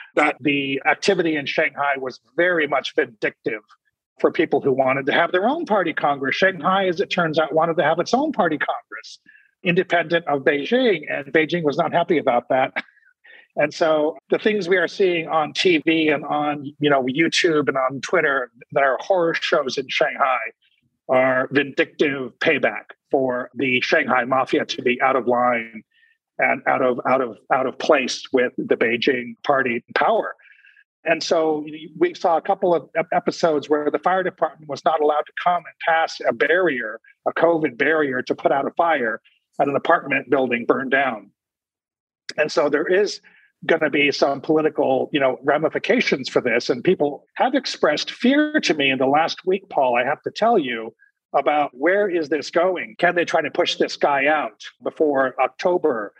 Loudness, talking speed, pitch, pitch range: -20 LUFS, 185 wpm, 160 Hz, 140-185 Hz